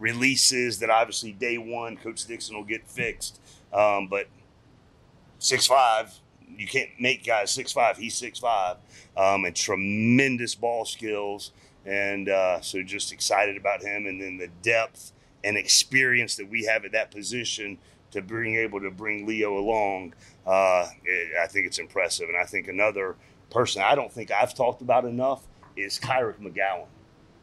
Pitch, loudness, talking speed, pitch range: 105 Hz, -25 LUFS, 160 wpm, 100-115 Hz